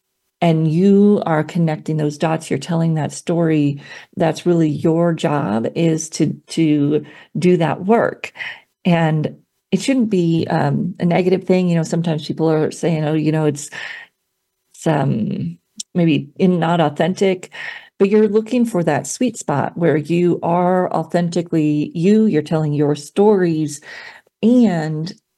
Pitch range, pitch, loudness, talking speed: 155-195 Hz, 170 Hz, -17 LUFS, 145 wpm